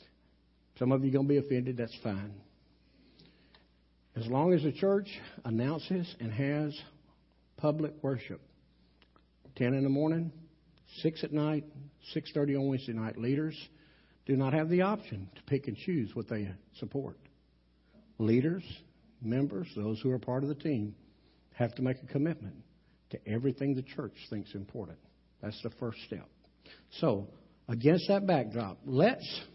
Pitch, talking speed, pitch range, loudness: 130 Hz, 145 wpm, 110-150 Hz, -33 LUFS